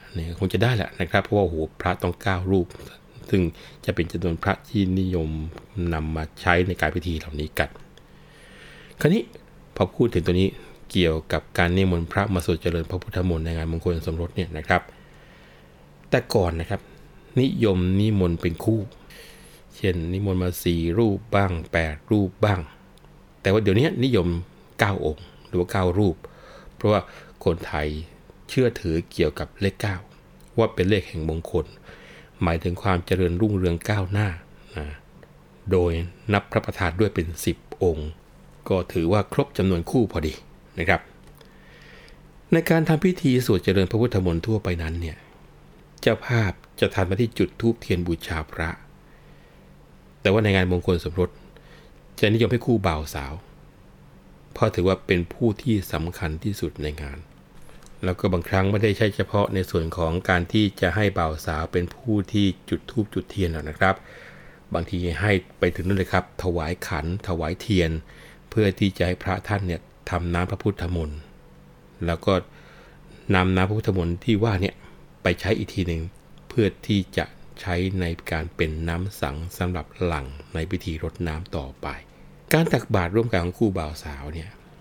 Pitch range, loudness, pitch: 85-100 Hz, -24 LUFS, 90 Hz